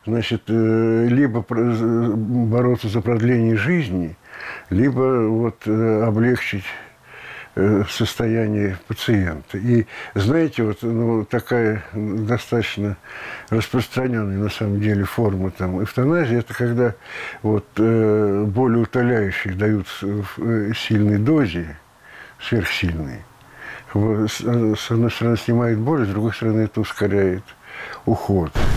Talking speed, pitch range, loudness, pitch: 95 wpm, 105-120 Hz, -20 LUFS, 110 Hz